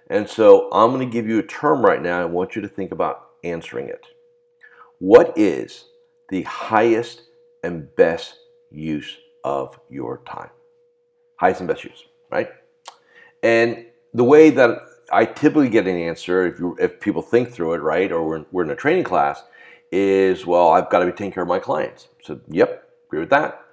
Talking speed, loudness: 185 wpm, -19 LUFS